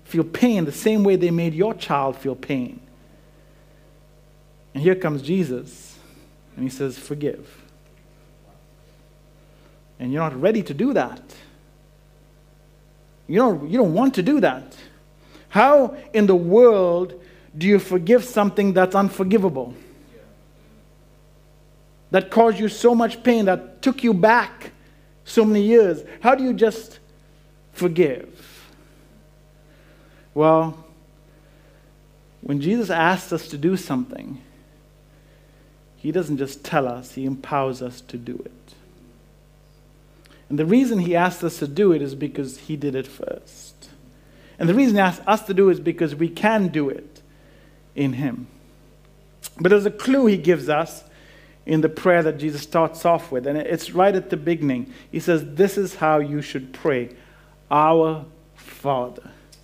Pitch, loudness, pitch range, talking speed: 155 Hz, -20 LUFS, 150-185 Hz, 145 wpm